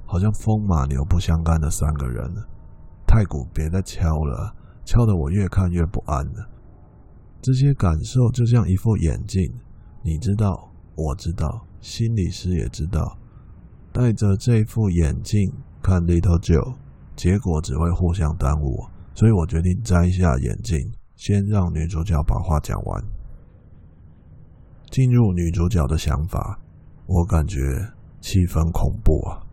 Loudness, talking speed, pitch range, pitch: -22 LUFS, 215 characters per minute, 80-105 Hz, 90 Hz